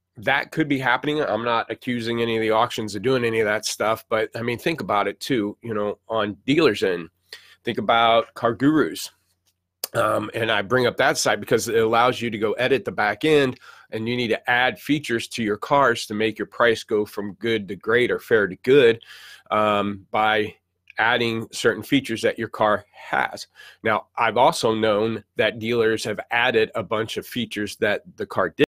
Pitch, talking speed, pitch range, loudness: 115 Hz, 200 wpm, 105-120 Hz, -22 LUFS